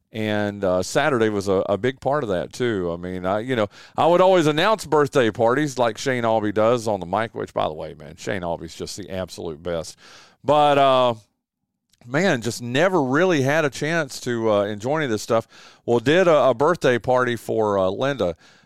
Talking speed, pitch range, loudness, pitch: 210 wpm, 100-140 Hz, -21 LUFS, 115 Hz